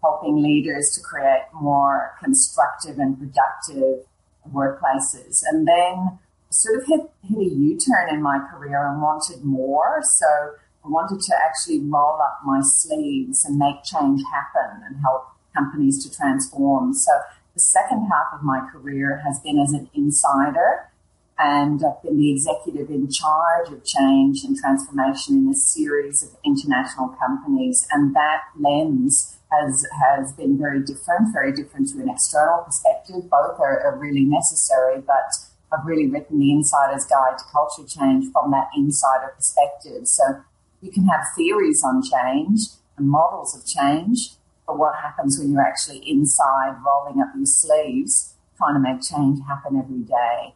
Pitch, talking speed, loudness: 150 Hz, 160 wpm, -20 LUFS